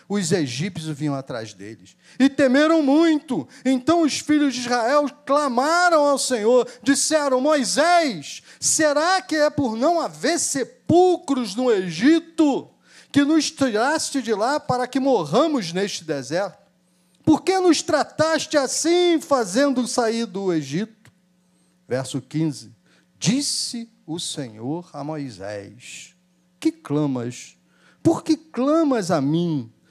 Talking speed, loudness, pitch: 120 wpm, -21 LUFS, 250 Hz